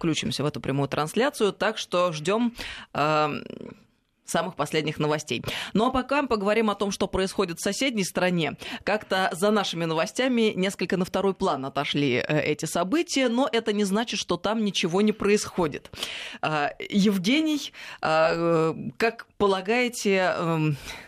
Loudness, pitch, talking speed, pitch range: -25 LUFS, 195 Hz, 140 wpm, 160-220 Hz